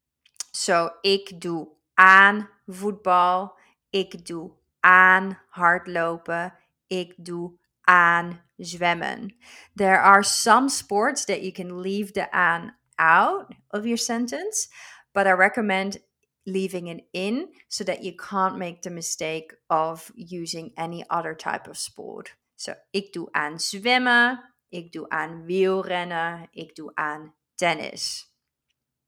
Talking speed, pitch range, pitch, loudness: 125 wpm, 170-200 Hz, 185 Hz, -22 LUFS